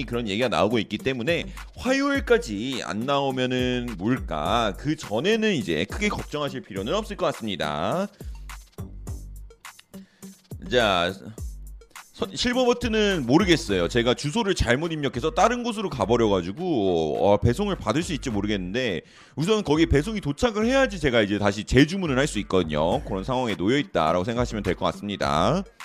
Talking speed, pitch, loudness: 335 characters per minute, 140 Hz, -24 LUFS